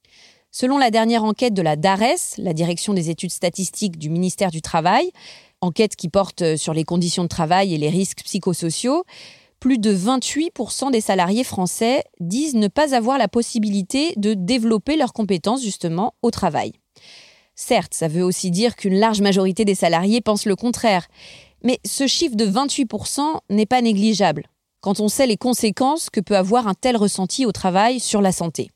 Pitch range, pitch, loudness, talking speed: 185-245 Hz, 210 Hz, -19 LUFS, 175 wpm